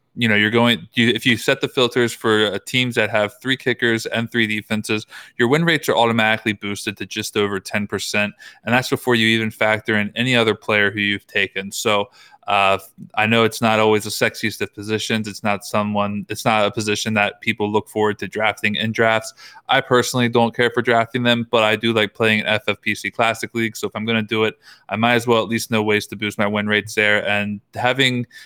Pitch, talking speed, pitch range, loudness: 110 Hz, 225 wpm, 105-115 Hz, -19 LUFS